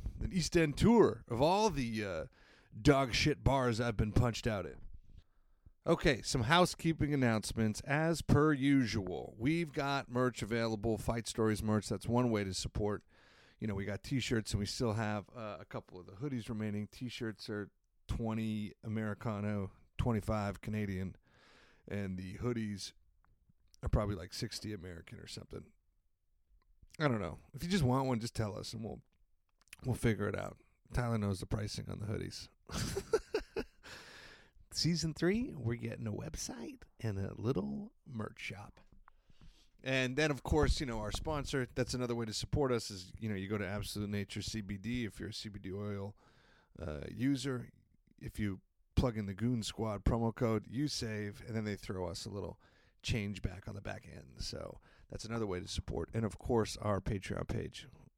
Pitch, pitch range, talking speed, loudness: 110 Hz, 100-125 Hz, 175 wpm, -36 LUFS